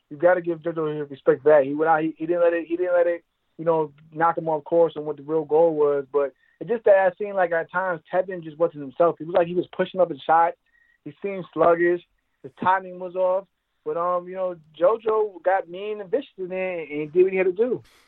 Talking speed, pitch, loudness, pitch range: 255 wpm, 175 Hz, -23 LUFS, 160-185 Hz